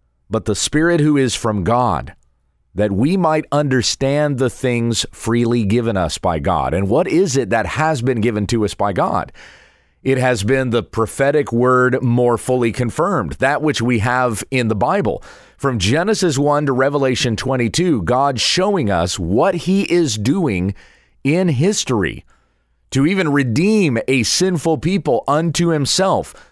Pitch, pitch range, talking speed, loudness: 125 Hz, 115-150 Hz, 155 wpm, -17 LUFS